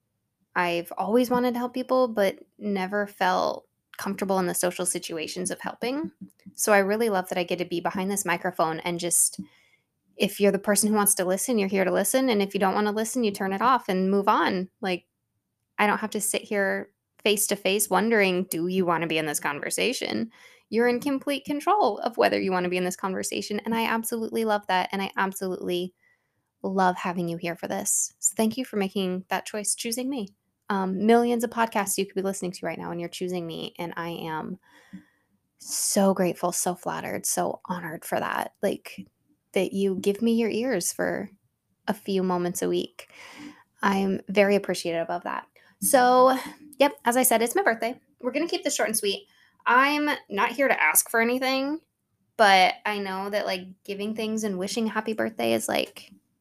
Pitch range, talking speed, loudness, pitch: 180-230 Hz, 200 wpm, -25 LUFS, 195 Hz